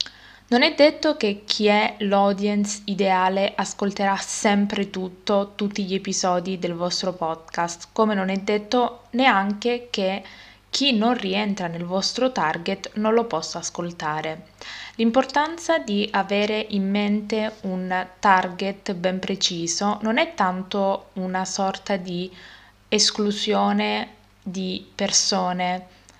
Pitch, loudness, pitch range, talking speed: 200 Hz, -23 LUFS, 185-210 Hz, 115 wpm